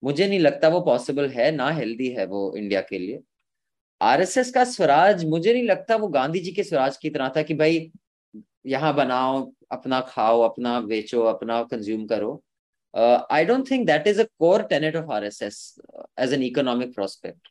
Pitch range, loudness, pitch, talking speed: 120-175 Hz, -22 LUFS, 140 Hz, 180 wpm